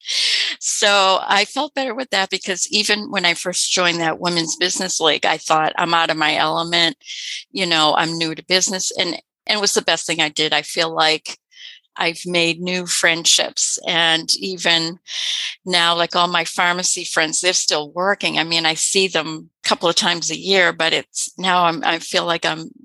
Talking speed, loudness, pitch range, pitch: 195 wpm, -17 LUFS, 165-190 Hz, 175 Hz